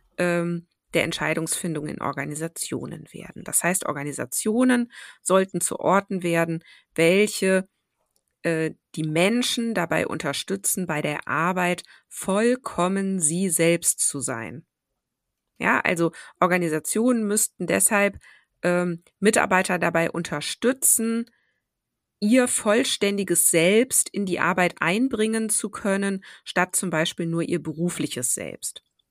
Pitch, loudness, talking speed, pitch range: 180 Hz, -23 LUFS, 100 wpm, 165-205 Hz